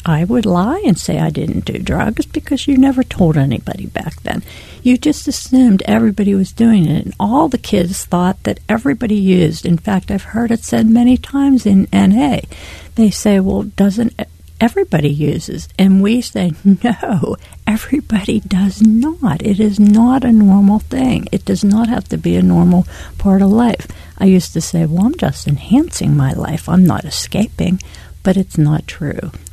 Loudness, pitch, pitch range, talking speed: -14 LUFS, 205 Hz, 180-235 Hz, 180 wpm